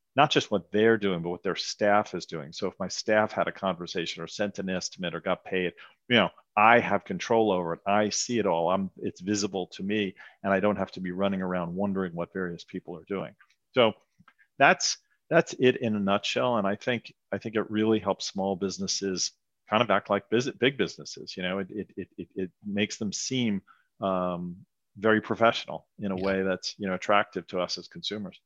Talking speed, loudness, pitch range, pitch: 215 wpm, -28 LUFS, 95-105 Hz, 100 Hz